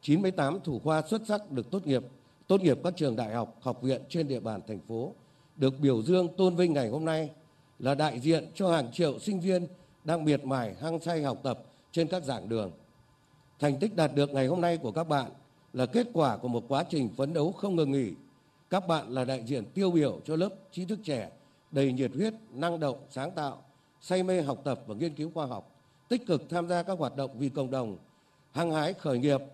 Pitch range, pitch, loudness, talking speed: 135-170 Hz, 145 Hz, -31 LUFS, 230 wpm